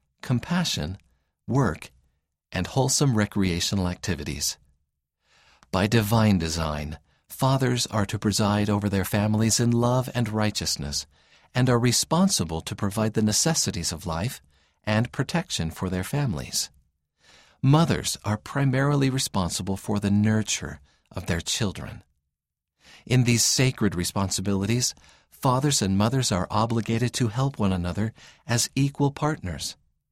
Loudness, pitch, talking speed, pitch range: -25 LUFS, 105 Hz, 120 wpm, 90-125 Hz